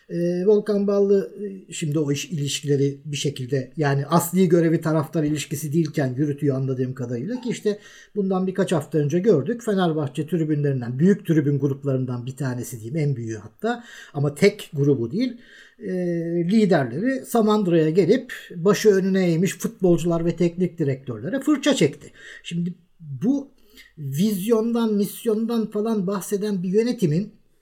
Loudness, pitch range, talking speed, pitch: -22 LUFS, 145-210 Hz, 135 wpm, 175 Hz